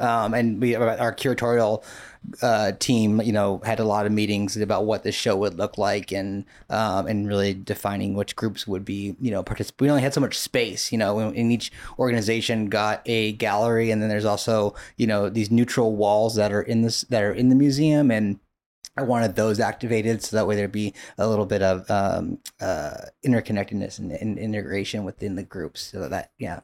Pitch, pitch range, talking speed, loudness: 110 Hz, 100-115 Hz, 205 wpm, -23 LUFS